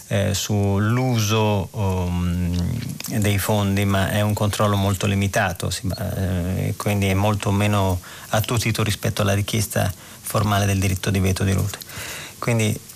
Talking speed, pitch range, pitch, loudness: 140 wpm, 95-110 Hz, 105 Hz, -22 LUFS